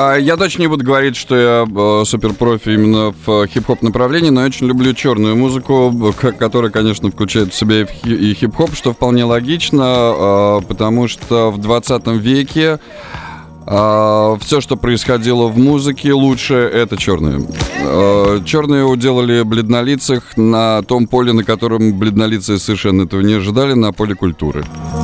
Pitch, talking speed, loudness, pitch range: 115 Hz, 140 wpm, -13 LUFS, 105-130 Hz